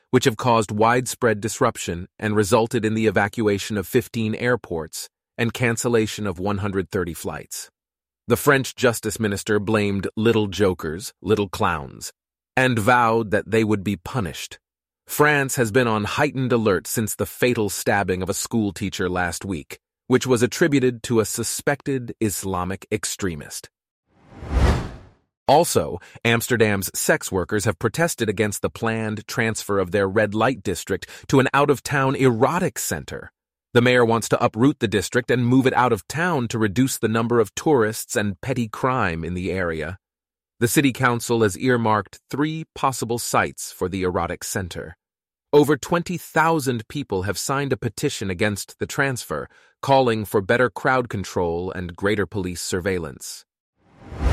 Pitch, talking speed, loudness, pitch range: 115 Hz, 150 wpm, -22 LUFS, 100-125 Hz